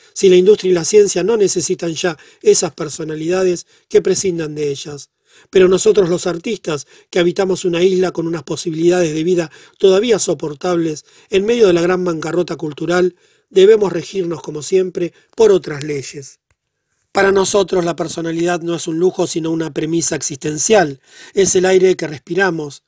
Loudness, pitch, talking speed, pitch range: -15 LUFS, 175 Hz, 160 wpm, 165-190 Hz